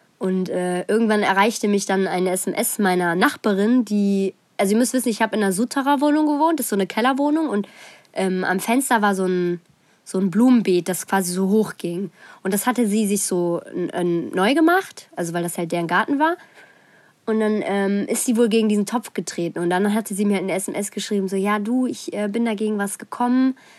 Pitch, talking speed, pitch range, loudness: 205 Hz, 215 wpm, 190-235 Hz, -21 LUFS